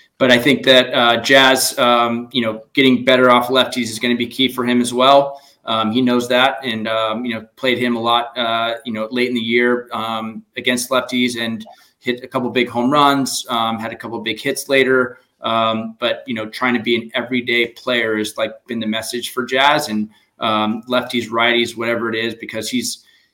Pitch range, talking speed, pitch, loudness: 115-125 Hz, 215 wpm, 120 Hz, -17 LUFS